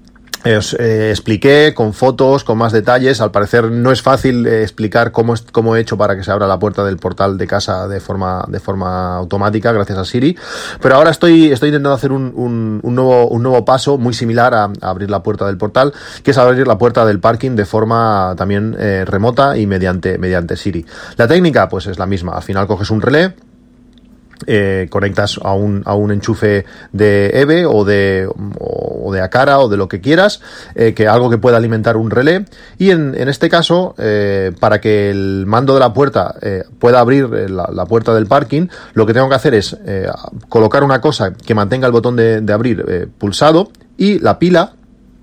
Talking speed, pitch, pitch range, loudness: 210 wpm, 115 Hz, 100-130 Hz, -12 LUFS